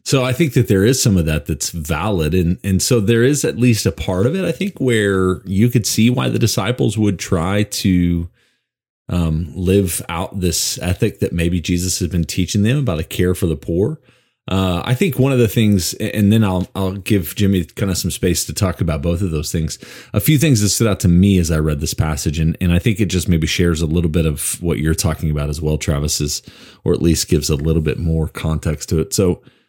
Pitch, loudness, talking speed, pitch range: 90 Hz, -17 LUFS, 245 wpm, 80-110 Hz